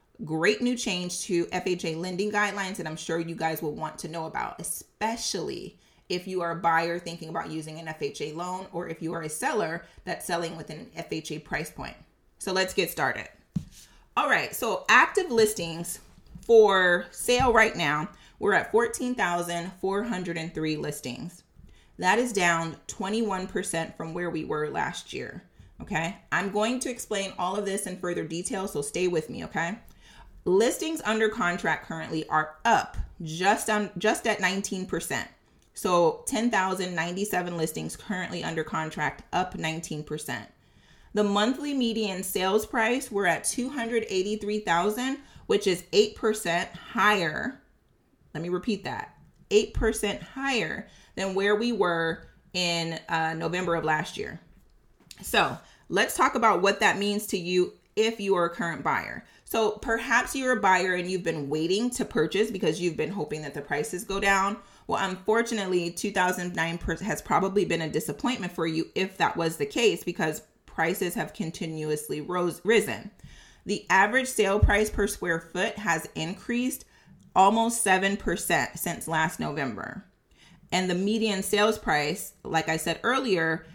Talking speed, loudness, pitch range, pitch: 150 wpm, -27 LUFS, 165-215 Hz, 185 Hz